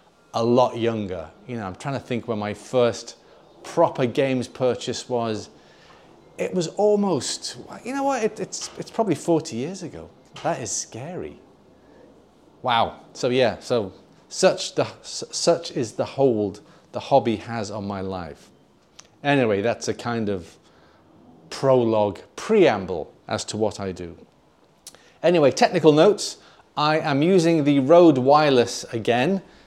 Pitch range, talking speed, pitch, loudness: 110-155 Hz, 140 wpm, 120 Hz, -22 LUFS